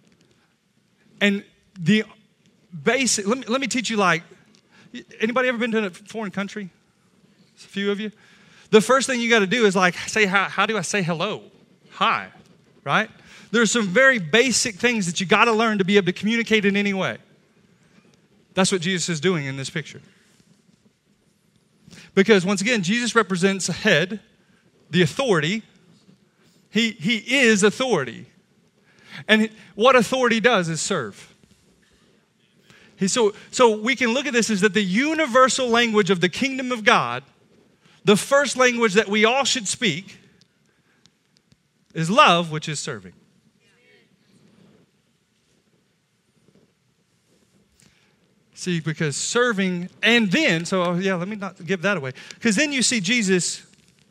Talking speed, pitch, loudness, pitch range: 145 wpm, 200 Hz, -20 LUFS, 185-220 Hz